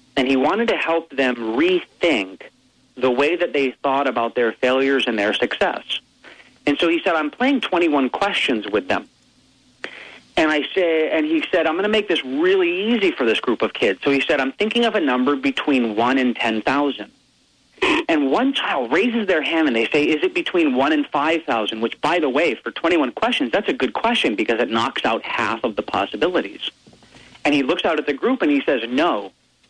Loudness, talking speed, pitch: -19 LUFS, 215 wpm, 160 Hz